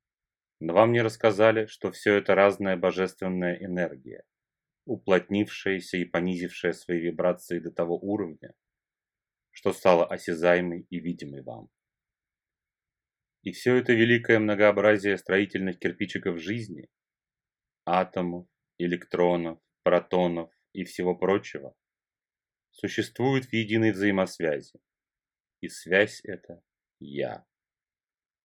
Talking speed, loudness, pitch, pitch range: 95 wpm, -26 LUFS, 95 Hz, 90-105 Hz